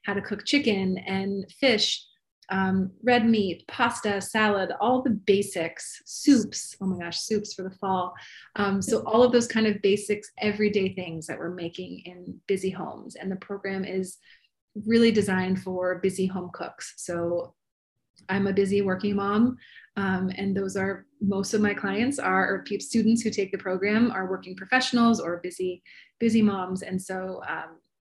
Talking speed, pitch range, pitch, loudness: 170 wpm, 185-215 Hz, 195 Hz, -26 LUFS